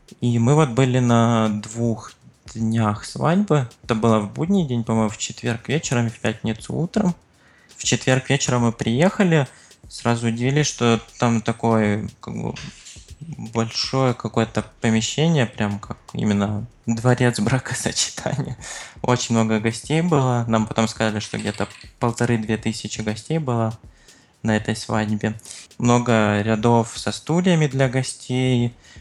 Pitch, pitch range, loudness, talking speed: 115 Hz, 110-130 Hz, -21 LUFS, 130 wpm